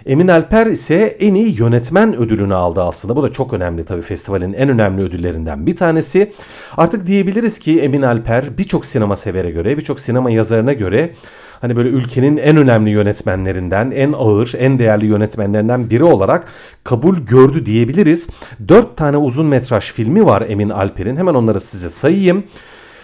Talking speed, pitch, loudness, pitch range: 160 wpm, 120 Hz, -14 LUFS, 105-155 Hz